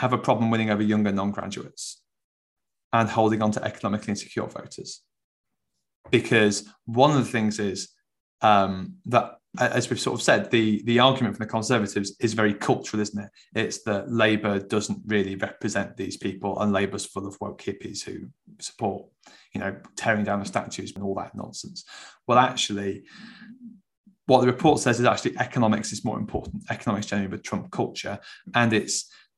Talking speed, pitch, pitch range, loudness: 170 wpm, 105 Hz, 100-120 Hz, -25 LUFS